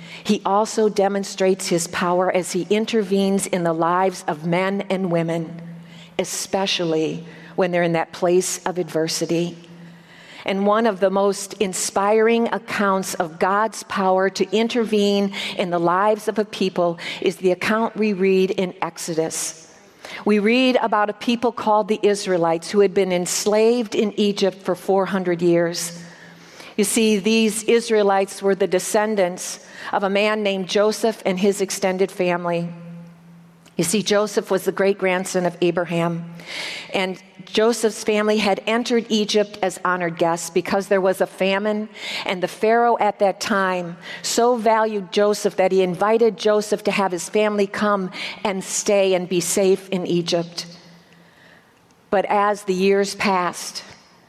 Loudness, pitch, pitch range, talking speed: -20 LUFS, 195 Hz, 180-210 Hz, 150 wpm